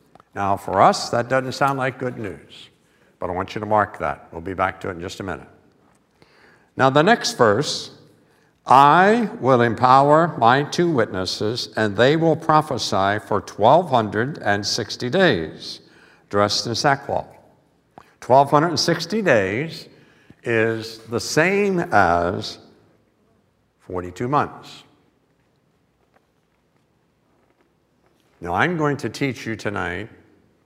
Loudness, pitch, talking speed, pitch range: -19 LUFS, 115 Hz, 115 wpm, 100-145 Hz